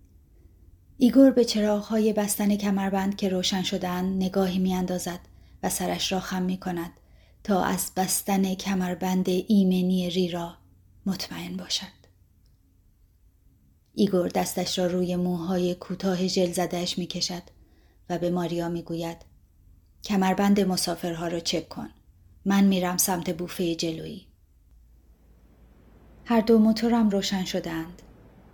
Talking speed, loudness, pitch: 120 wpm, -25 LUFS, 180 Hz